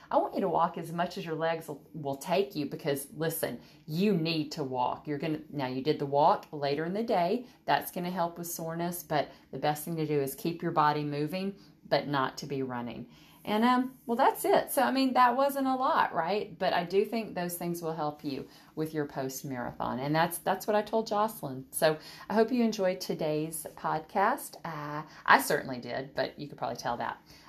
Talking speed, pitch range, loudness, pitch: 225 wpm, 145-190 Hz, -31 LUFS, 160 Hz